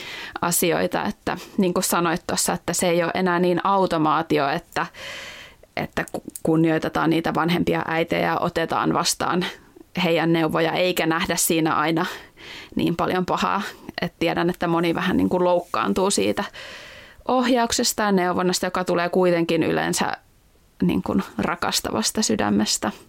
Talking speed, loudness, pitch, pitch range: 130 wpm, -22 LUFS, 175 Hz, 165-185 Hz